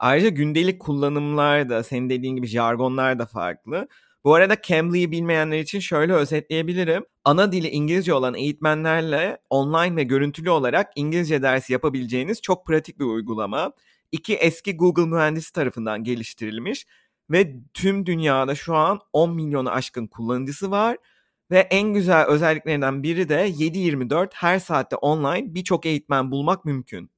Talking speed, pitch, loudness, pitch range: 135 wpm, 155 Hz, -22 LUFS, 135-175 Hz